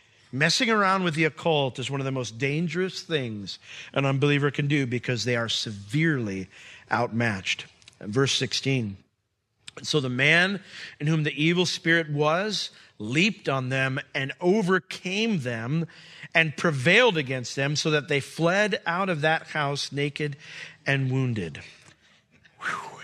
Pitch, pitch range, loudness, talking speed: 145 Hz, 130-165 Hz, -25 LUFS, 145 wpm